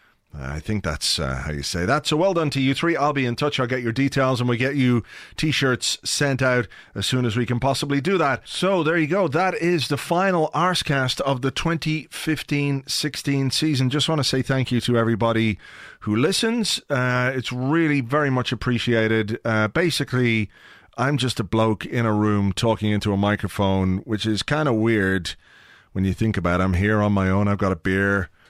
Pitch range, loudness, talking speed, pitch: 105-145 Hz, -22 LUFS, 210 wpm, 125 Hz